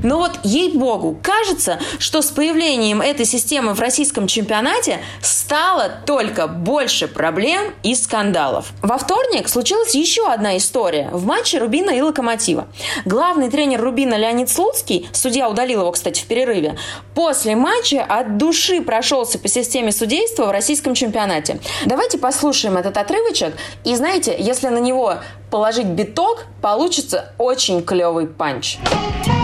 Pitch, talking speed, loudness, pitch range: 255 Hz, 135 wpm, -17 LUFS, 220-325 Hz